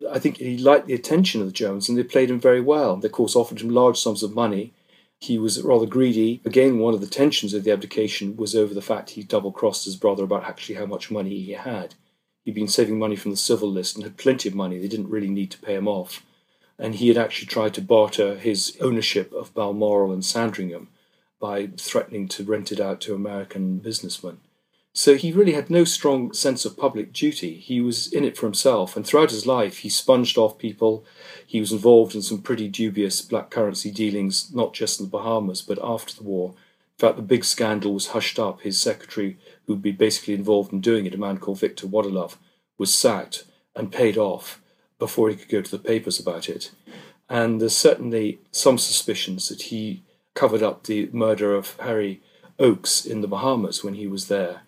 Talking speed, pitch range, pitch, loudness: 215 wpm, 100-115 Hz, 110 Hz, -22 LUFS